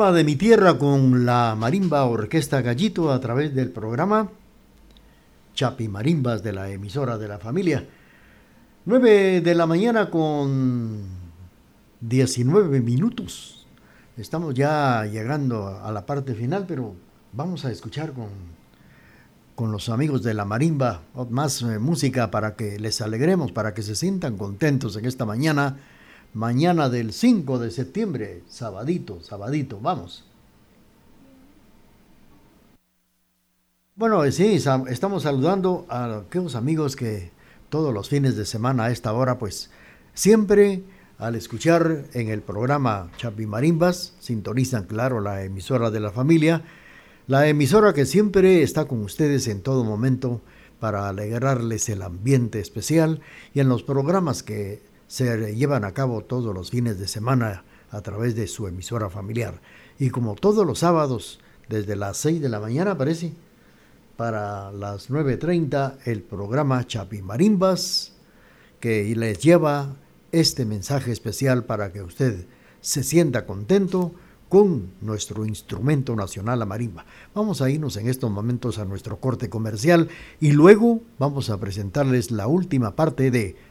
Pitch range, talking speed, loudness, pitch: 110-155 Hz, 135 wpm, -22 LUFS, 125 Hz